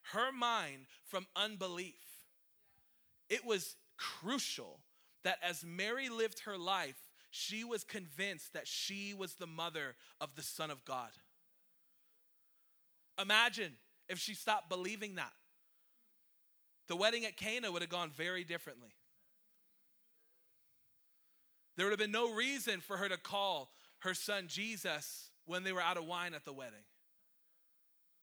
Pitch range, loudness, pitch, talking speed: 175-215 Hz, -39 LUFS, 190 Hz, 135 wpm